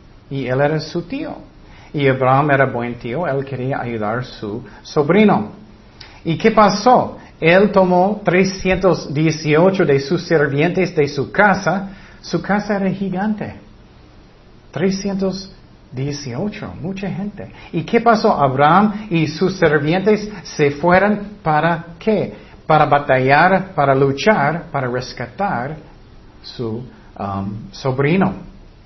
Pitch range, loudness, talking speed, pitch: 135-190 Hz, -17 LUFS, 115 wpm, 160 Hz